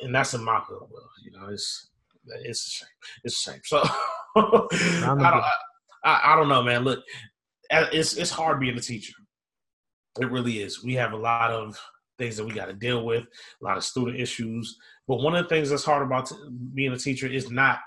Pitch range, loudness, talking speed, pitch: 115-145 Hz, -25 LUFS, 210 wpm, 125 Hz